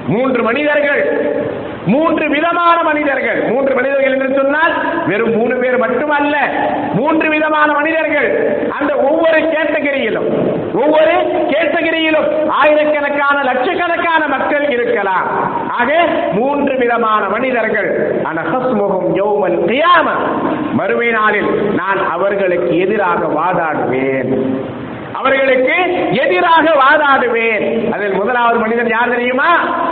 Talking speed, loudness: 95 wpm, -13 LUFS